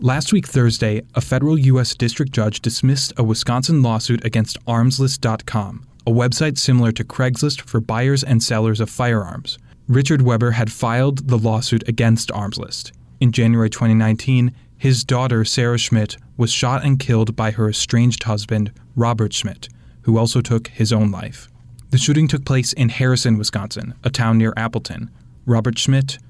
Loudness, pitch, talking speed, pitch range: -18 LUFS, 120 Hz, 155 wpm, 110-130 Hz